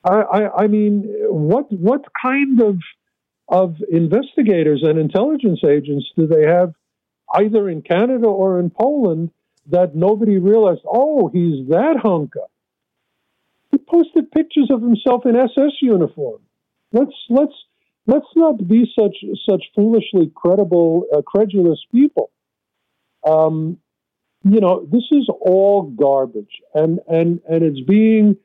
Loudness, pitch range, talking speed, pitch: -16 LUFS, 170-250 Hz, 125 wpm, 205 Hz